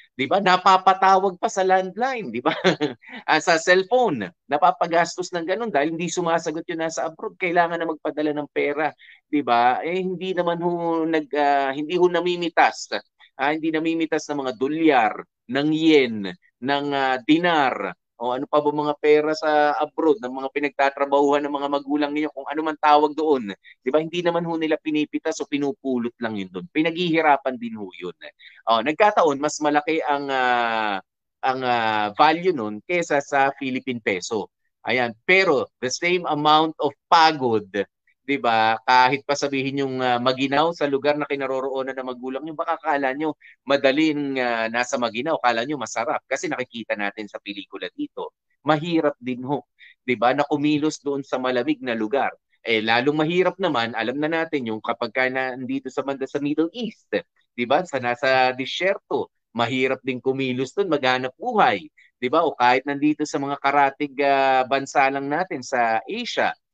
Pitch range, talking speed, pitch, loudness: 130-160 Hz, 165 wpm, 145 Hz, -22 LUFS